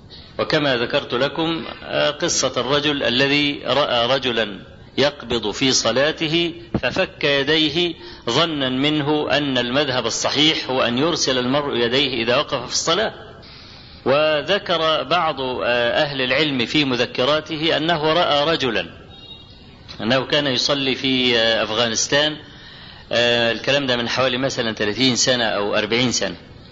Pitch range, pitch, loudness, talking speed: 120-150 Hz, 130 Hz, -19 LUFS, 115 wpm